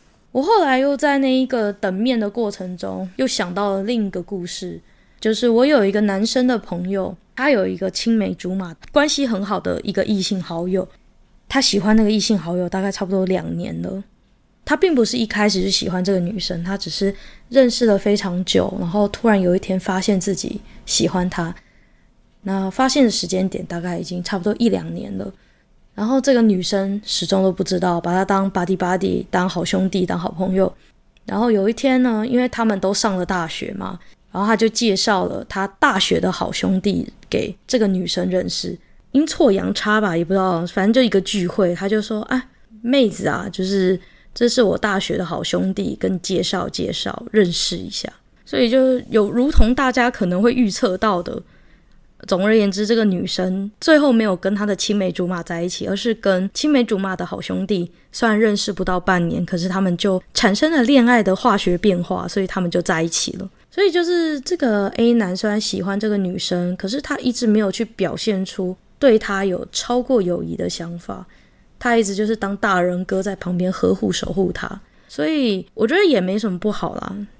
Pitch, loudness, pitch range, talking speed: 200 Hz, -19 LUFS, 185-230 Hz, 300 characters per minute